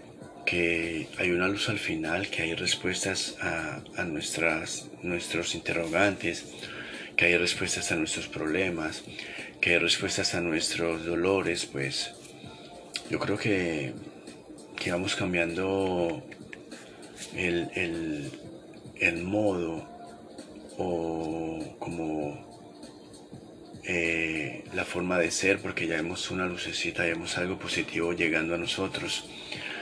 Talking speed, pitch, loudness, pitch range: 115 wpm, 85 Hz, -29 LUFS, 85-90 Hz